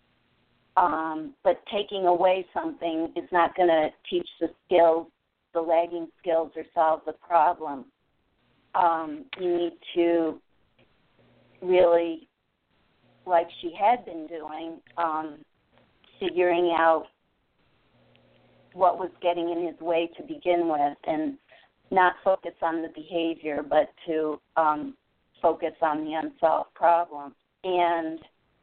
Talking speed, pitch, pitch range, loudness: 115 wpm, 165 Hz, 160-175 Hz, -26 LUFS